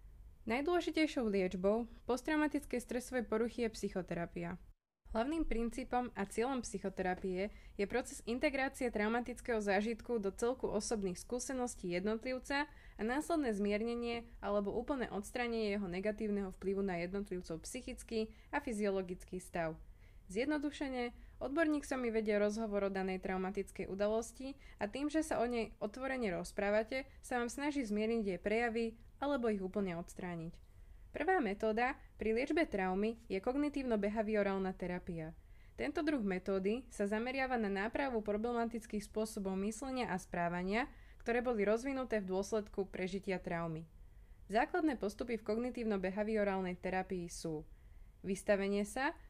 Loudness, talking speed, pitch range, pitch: -38 LUFS, 120 wpm, 195-245 Hz, 220 Hz